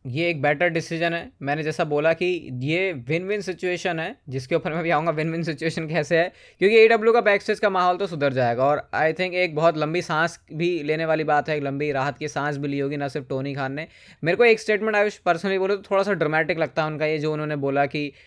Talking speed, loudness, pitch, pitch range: 260 wpm, -23 LUFS, 165 Hz, 150-180 Hz